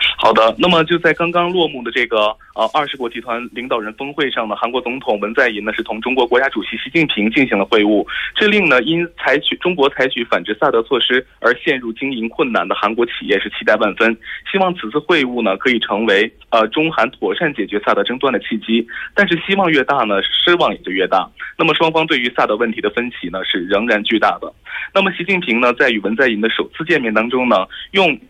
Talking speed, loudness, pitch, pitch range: 340 characters per minute, -16 LUFS, 130 Hz, 115-170 Hz